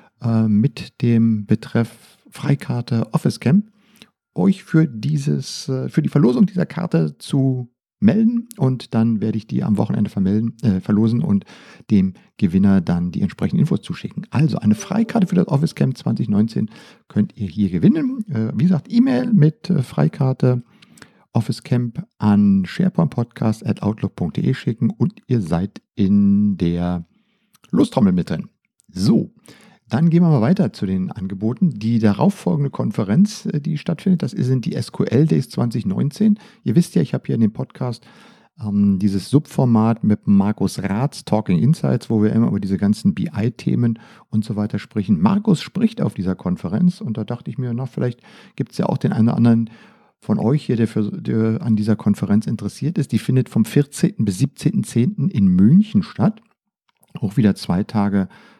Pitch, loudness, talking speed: 125 Hz, -19 LUFS, 165 wpm